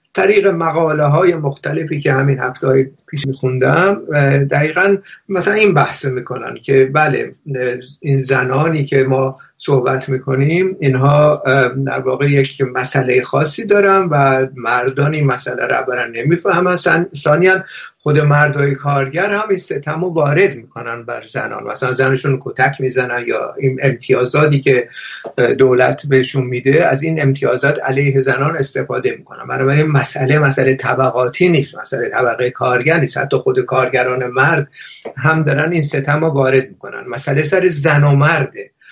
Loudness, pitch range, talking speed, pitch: -14 LUFS, 130-155 Hz, 145 wpm, 140 Hz